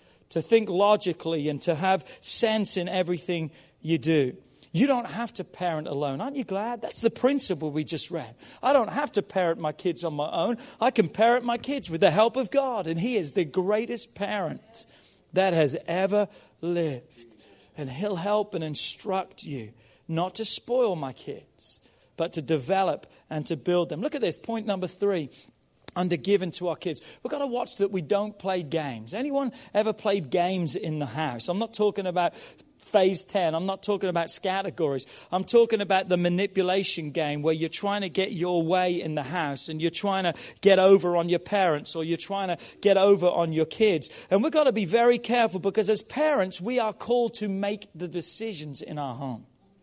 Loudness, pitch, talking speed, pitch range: -26 LUFS, 185 Hz, 200 wpm, 165-210 Hz